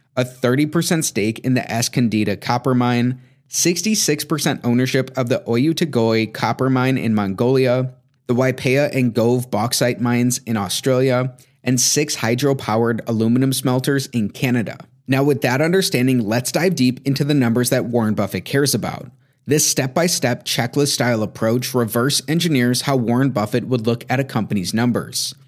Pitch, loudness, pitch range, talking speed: 130 Hz, -18 LUFS, 120-135 Hz, 145 wpm